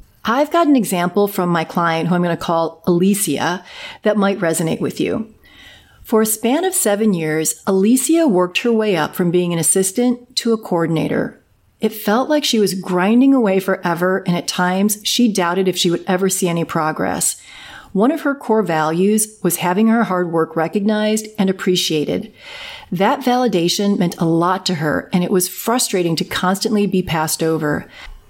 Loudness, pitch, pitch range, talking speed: -17 LUFS, 190 Hz, 175-220 Hz, 180 wpm